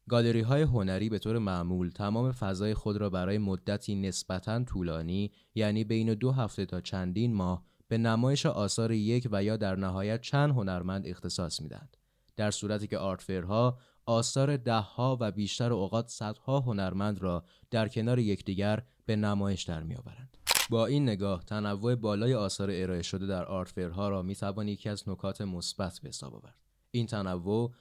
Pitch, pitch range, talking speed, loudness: 105 Hz, 95-115 Hz, 160 wpm, -32 LUFS